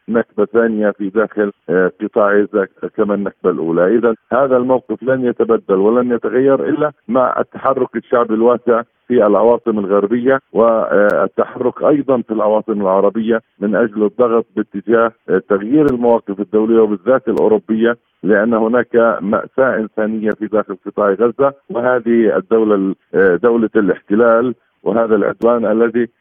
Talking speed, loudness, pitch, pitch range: 120 wpm, -15 LUFS, 115 Hz, 105-120 Hz